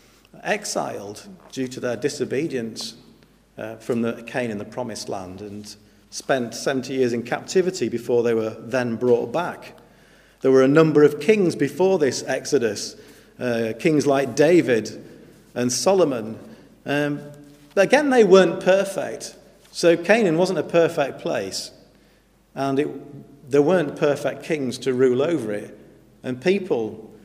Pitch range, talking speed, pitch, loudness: 120-170 Hz, 140 wpm, 140 Hz, -21 LUFS